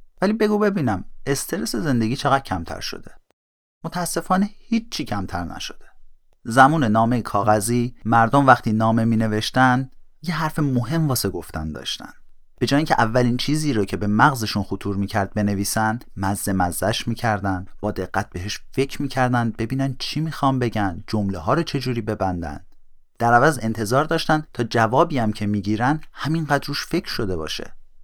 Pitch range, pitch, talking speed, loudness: 105-145 Hz, 120 Hz, 150 wpm, -21 LUFS